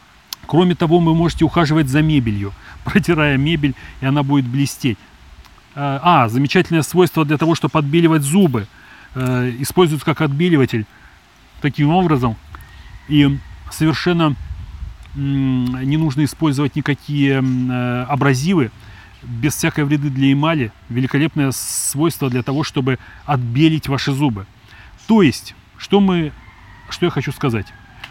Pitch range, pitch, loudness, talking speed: 115-155 Hz, 140 Hz, -17 LUFS, 115 wpm